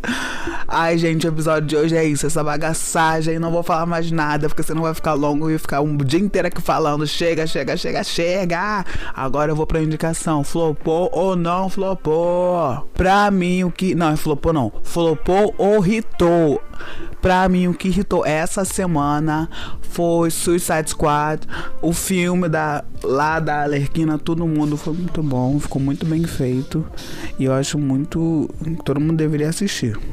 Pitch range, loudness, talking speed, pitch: 150-175 Hz, -19 LUFS, 165 wpm, 160 Hz